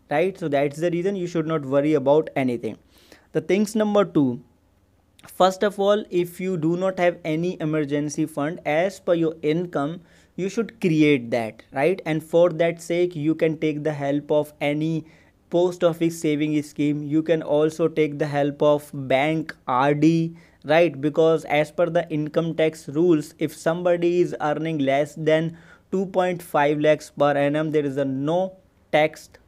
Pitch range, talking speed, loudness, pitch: 145-175 Hz, 175 wpm, -22 LUFS, 155 Hz